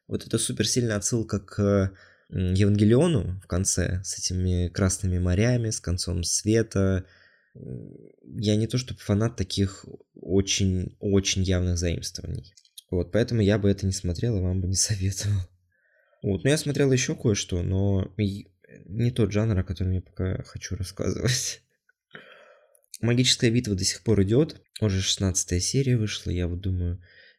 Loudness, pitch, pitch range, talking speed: -25 LUFS, 100 Hz, 95-110 Hz, 145 wpm